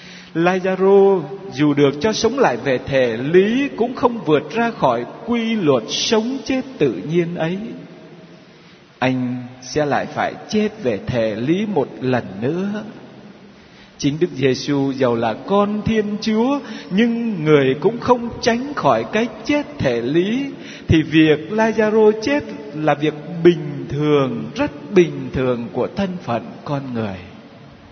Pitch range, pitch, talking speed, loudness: 145-220 Hz, 185 Hz, 140 wpm, -18 LUFS